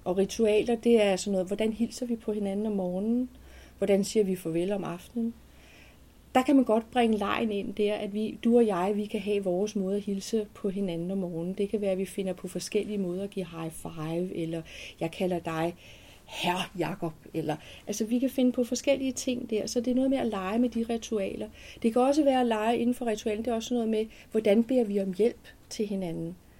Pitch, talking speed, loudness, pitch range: 210 Hz, 230 wpm, -29 LUFS, 185-230 Hz